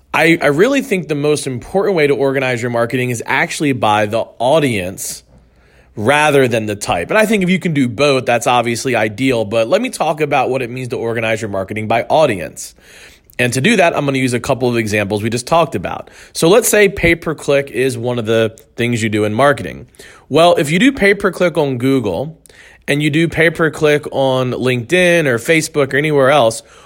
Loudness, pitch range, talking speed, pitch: -14 LUFS, 115-160 Hz, 215 wpm, 135 Hz